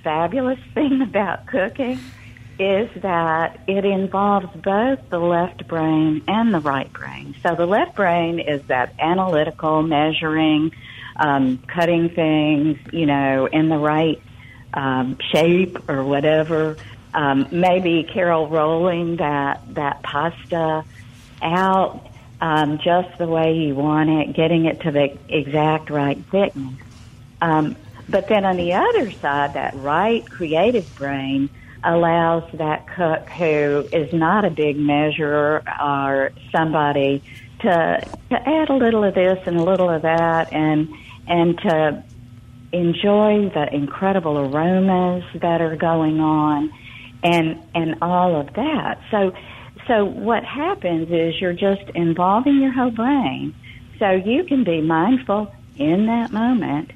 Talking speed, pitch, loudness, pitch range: 135 wpm, 160 Hz, -19 LUFS, 145-185 Hz